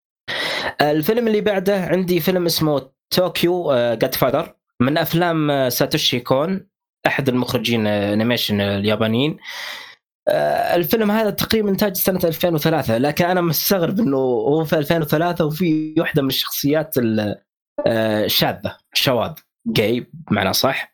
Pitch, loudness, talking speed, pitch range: 160 Hz, -19 LUFS, 115 wpm, 130-190 Hz